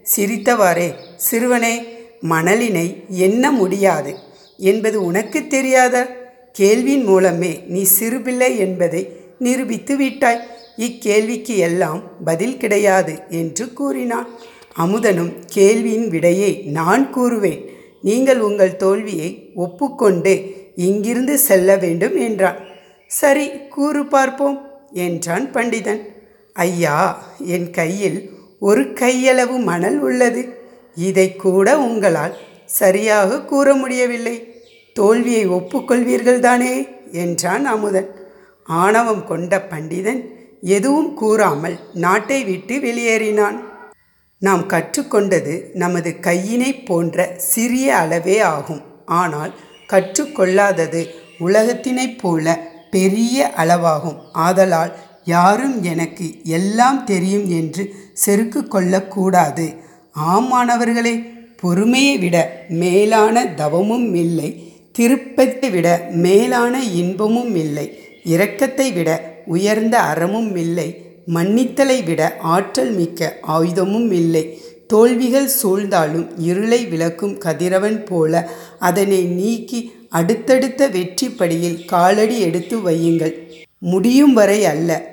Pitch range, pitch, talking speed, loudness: 175-235 Hz, 195 Hz, 90 wpm, -16 LUFS